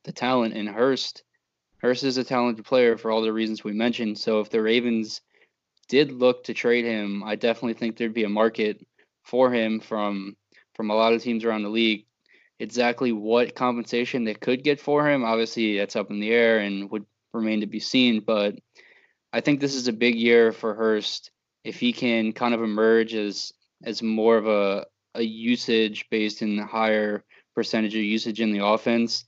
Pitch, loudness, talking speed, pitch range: 115 Hz, -24 LUFS, 195 wpm, 110-120 Hz